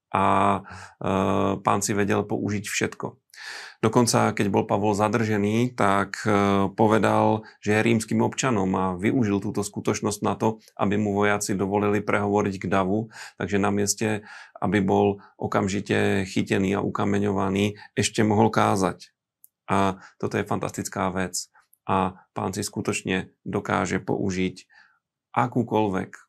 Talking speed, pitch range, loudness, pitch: 125 wpm, 100-110 Hz, -24 LUFS, 105 Hz